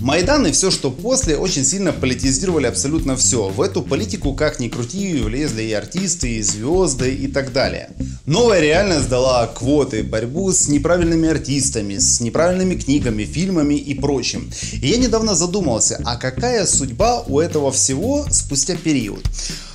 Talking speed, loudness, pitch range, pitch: 150 wpm, -17 LUFS, 120-170 Hz, 140 Hz